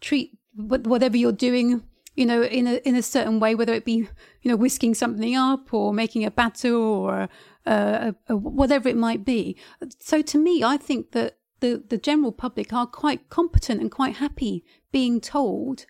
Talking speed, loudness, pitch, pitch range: 190 wpm, -23 LUFS, 245 Hz, 230-270 Hz